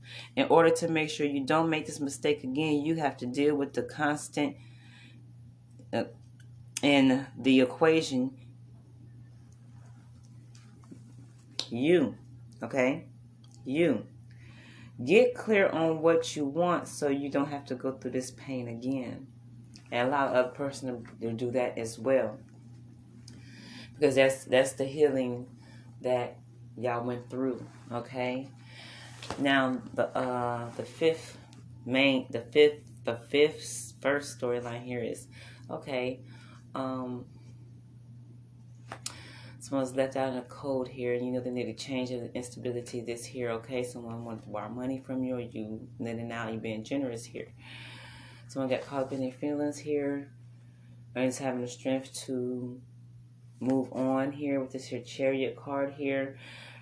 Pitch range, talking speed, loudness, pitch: 120-135 Hz, 145 wpm, -30 LUFS, 125 Hz